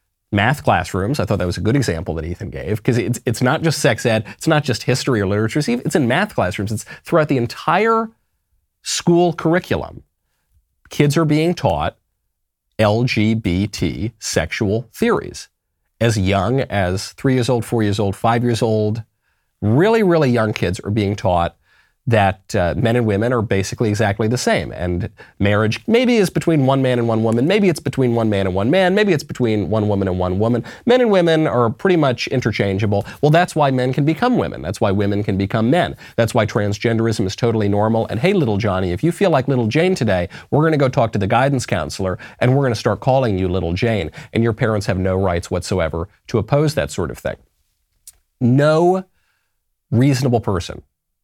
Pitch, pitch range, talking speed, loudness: 115 Hz, 100-135 Hz, 200 wpm, -18 LUFS